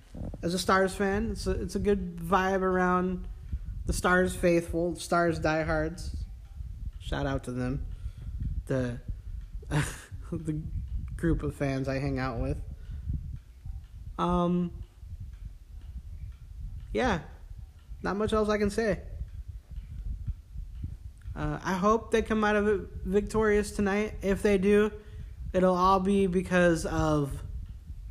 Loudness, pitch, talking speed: -29 LUFS, 125 Hz, 115 wpm